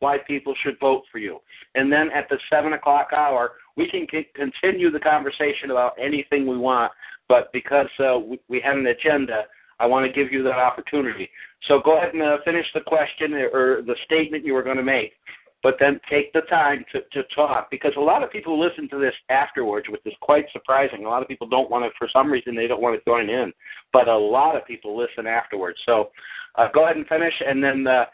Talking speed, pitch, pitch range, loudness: 230 wpm, 140 Hz, 130-155 Hz, -21 LUFS